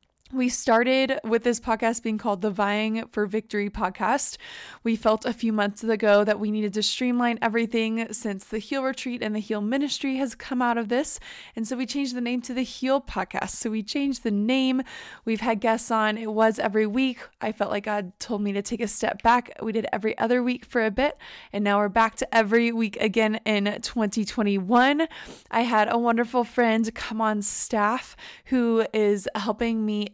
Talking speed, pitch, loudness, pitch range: 200 wpm, 225 Hz, -25 LUFS, 215-250 Hz